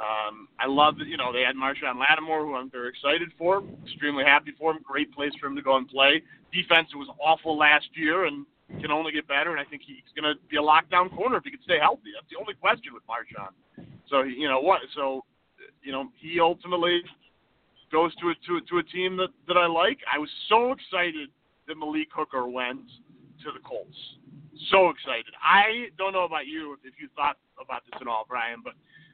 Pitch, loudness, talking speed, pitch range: 155 Hz, -25 LUFS, 220 wpm, 140-175 Hz